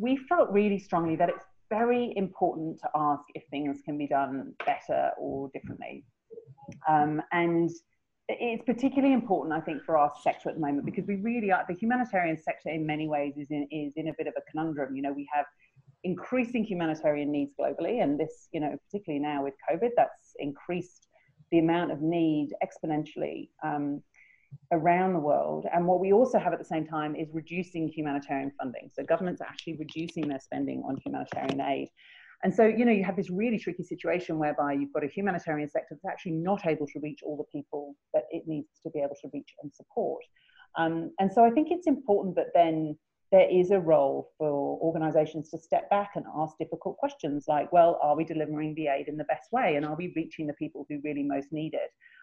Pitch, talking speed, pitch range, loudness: 160 Hz, 205 wpm, 150-185 Hz, -29 LUFS